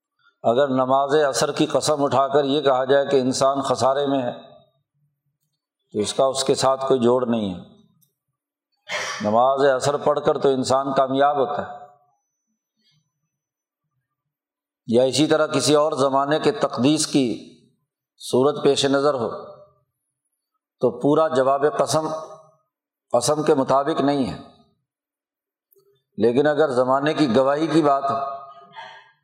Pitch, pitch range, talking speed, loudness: 145 Hz, 135-155 Hz, 130 wpm, -20 LUFS